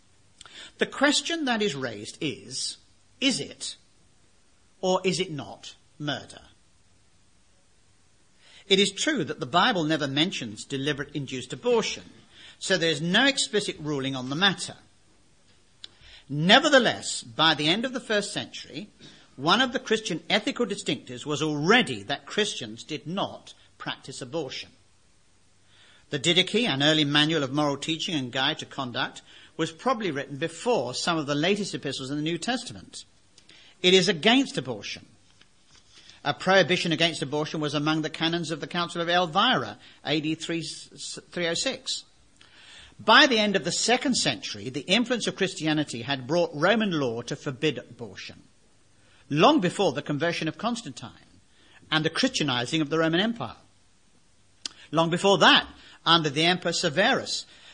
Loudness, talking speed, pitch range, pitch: -25 LUFS, 140 wpm, 130-190 Hz, 155 Hz